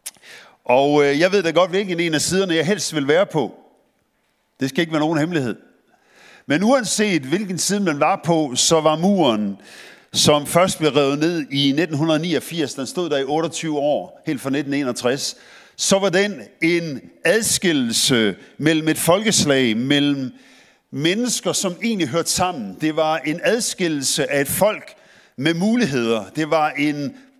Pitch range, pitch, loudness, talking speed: 145-180 Hz, 160 Hz, -19 LUFS, 160 wpm